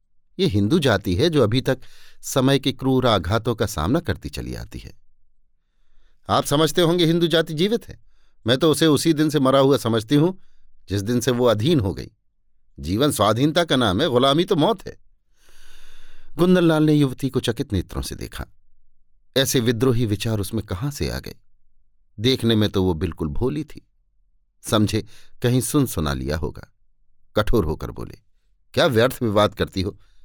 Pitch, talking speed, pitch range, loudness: 120 Hz, 170 wpm, 100-145 Hz, -20 LUFS